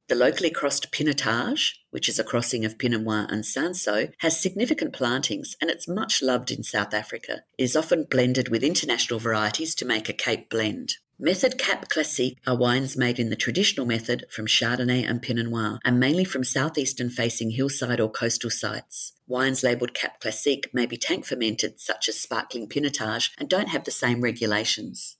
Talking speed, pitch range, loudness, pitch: 185 wpm, 115-140 Hz, -24 LUFS, 125 Hz